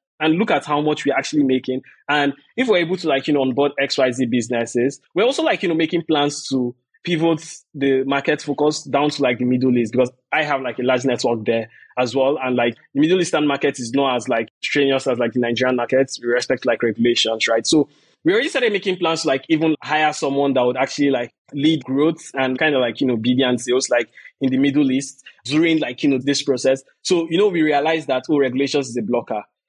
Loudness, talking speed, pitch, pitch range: -19 LUFS, 235 wpm, 140 Hz, 130-150 Hz